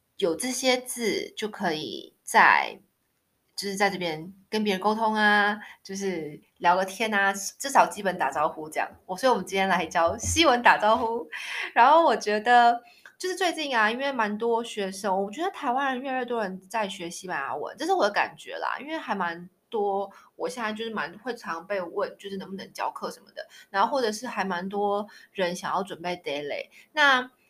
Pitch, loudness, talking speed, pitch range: 210 Hz, -26 LUFS, 290 characters per minute, 185-240 Hz